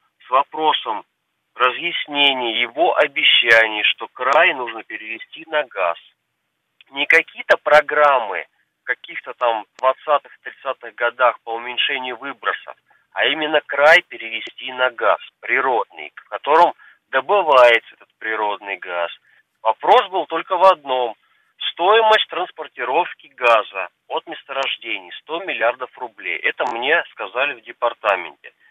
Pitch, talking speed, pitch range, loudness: 130 Hz, 115 wpm, 115-155 Hz, -18 LUFS